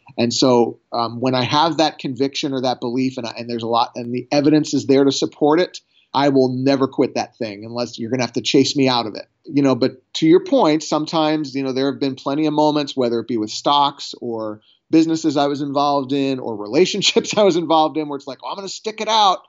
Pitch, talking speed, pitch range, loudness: 140 Hz, 255 wpm, 125-155 Hz, -18 LUFS